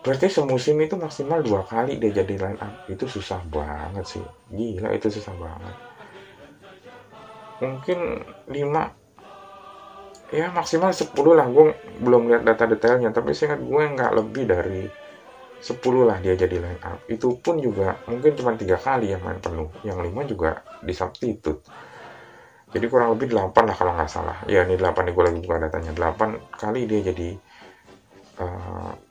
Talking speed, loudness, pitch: 160 wpm, -23 LUFS, 115 Hz